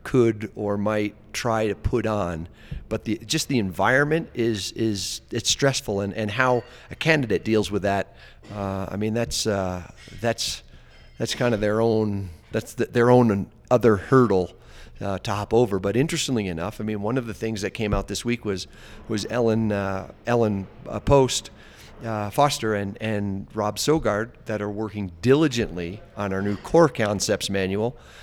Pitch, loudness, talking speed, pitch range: 110 Hz, -24 LUFS, 170 wpm, 100-120 Hz